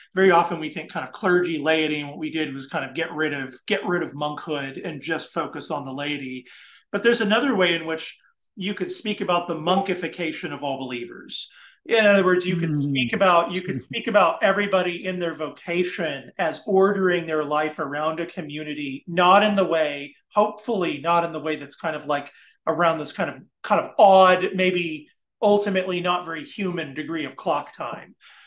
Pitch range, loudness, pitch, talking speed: 150-185 Hz, -23 LUFS, 165 Hz, 200 wpm